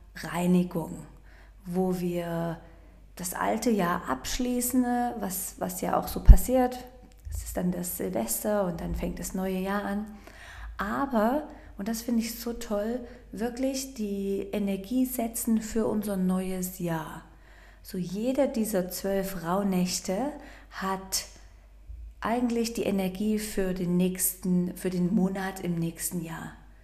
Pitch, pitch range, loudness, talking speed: 190 Hz, 180-230 Hz, -29 LUFS, 130 wpm